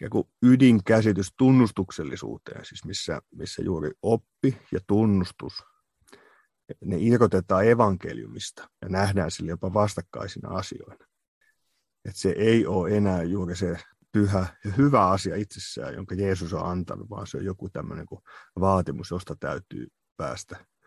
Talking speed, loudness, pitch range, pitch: 125 wpm, -25 LUFS, 90-110 Hz, 100 Hz